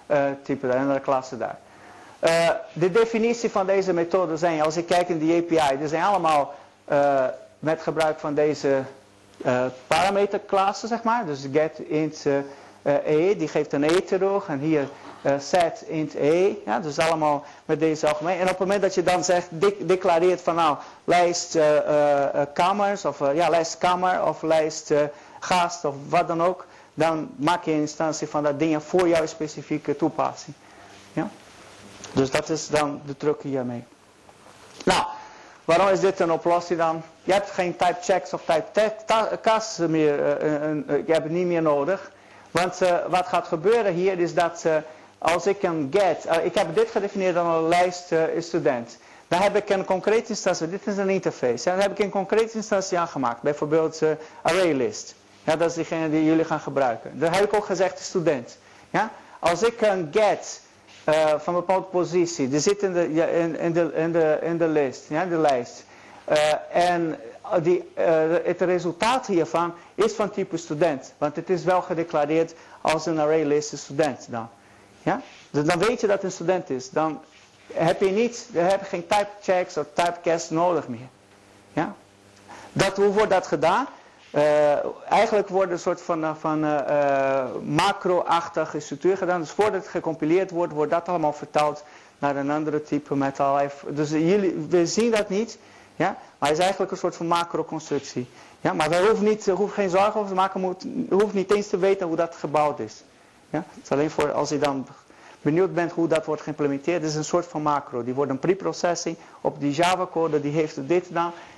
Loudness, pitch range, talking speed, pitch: -23 LUFS, 150-185 Hz, 195 wpm, 165 Hz